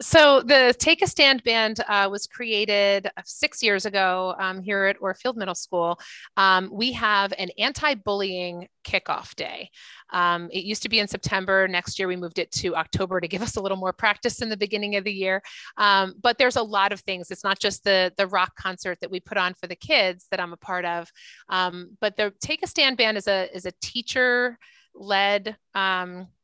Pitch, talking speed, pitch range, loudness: 200 Hz, 215 wpm, 185-220 Hz, -23 LUFS